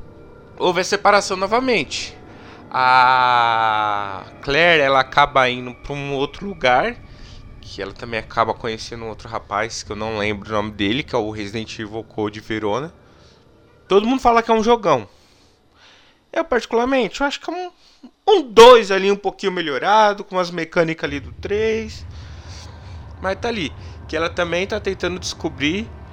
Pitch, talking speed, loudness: 135 Hz, 165 wpm, -18 LUFS